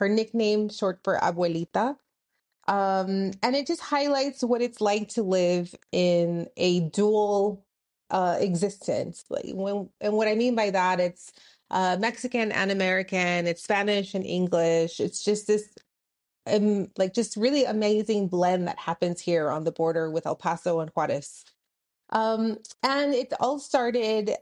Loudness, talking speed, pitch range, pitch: -26 LUFS, 150 wpm, 180-225 Hz, 200 Hz